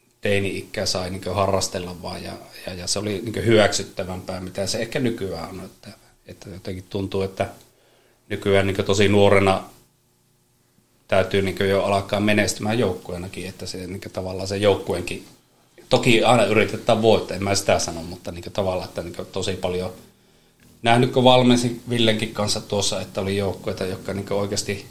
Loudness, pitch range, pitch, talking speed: -22 LUFS, 95-105 Hz, 100 Hz, 160 wpm